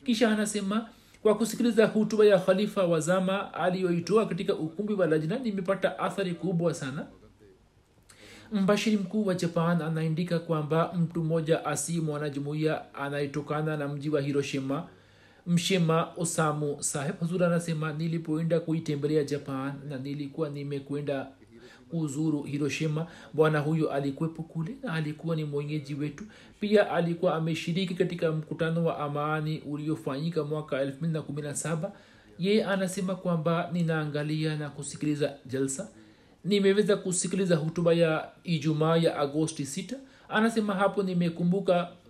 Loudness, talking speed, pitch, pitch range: -29 LUFS, 115 wpm, 165 Hz, 150-190 Hz